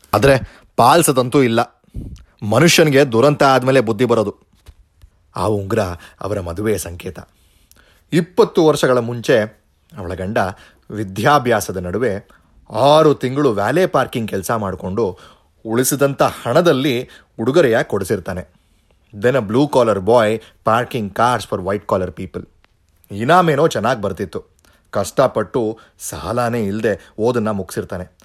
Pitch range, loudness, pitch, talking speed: 90-130 Hz, -16 LUFS, 110 Hz, 105 wpm